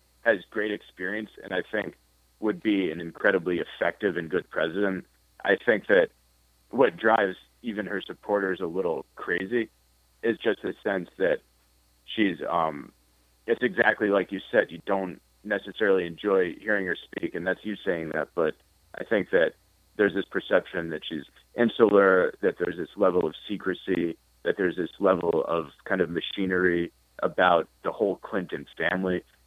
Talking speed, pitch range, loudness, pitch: 160 wpm, 60-95 Hz, -27 LUFS, 85 Hz